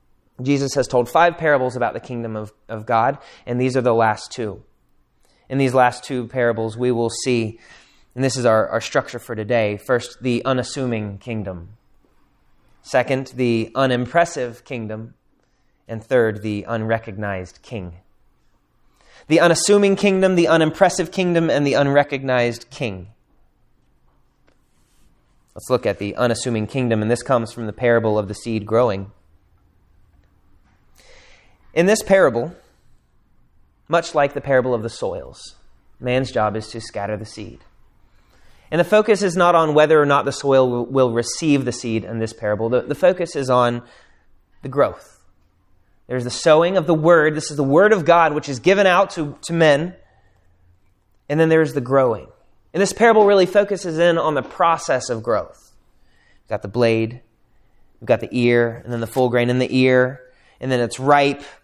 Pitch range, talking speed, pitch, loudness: 110-145 Hz, 165 wpm, 125 Hz, -19 LUFS